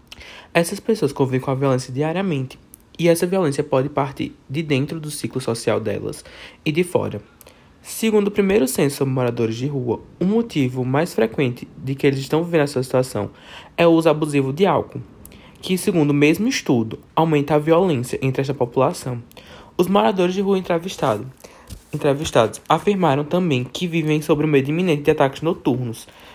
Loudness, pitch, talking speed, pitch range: -20 LUFS, 150 Hz, 170 wpm, 135-175 Hz